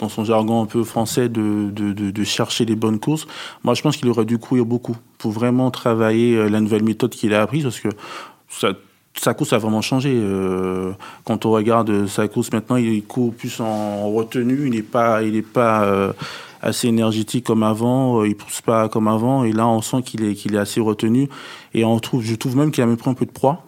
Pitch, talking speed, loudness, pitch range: 115 Hz, 230 wpm, -19 LUFS, 110-125 Hz